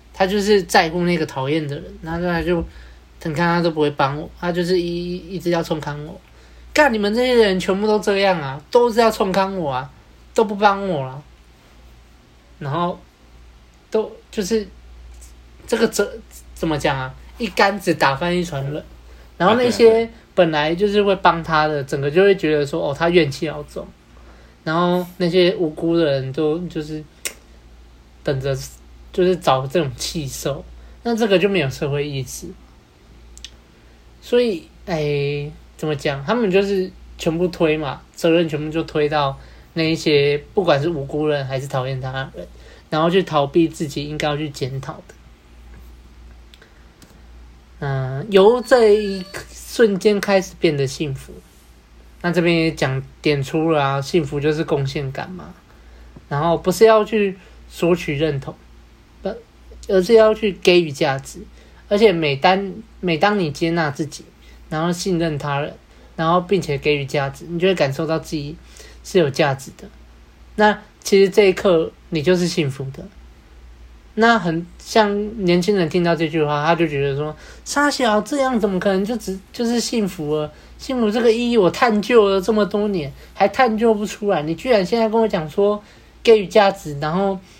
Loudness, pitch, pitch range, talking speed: -19 LUFS, 165 Hz, 140-195 Hz, 240 characters per minute